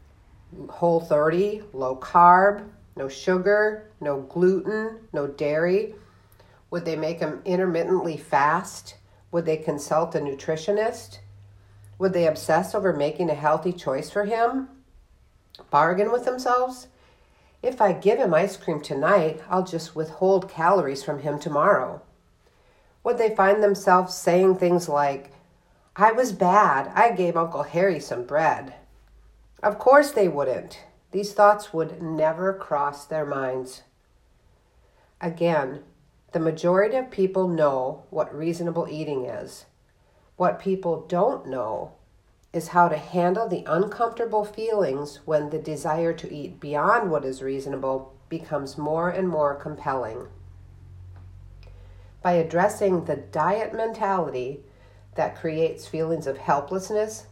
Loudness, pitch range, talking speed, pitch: -24 LUFS, 140-195 Hz, 125 wpm, 165 Hz